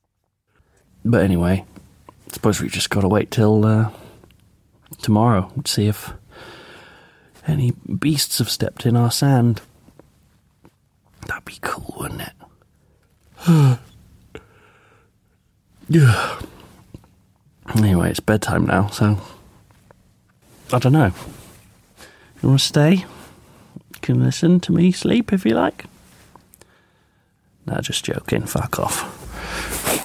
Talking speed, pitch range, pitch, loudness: 110 wpm, 95-130 Hz, 105 Hz, -19 LUFS